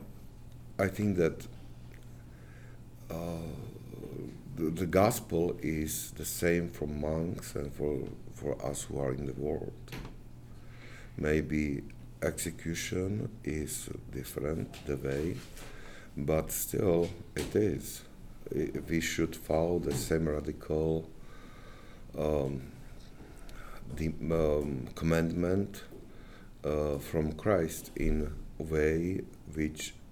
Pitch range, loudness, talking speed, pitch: 70-85 Hz, -33 LUFS, 95 wpm, 75 Hz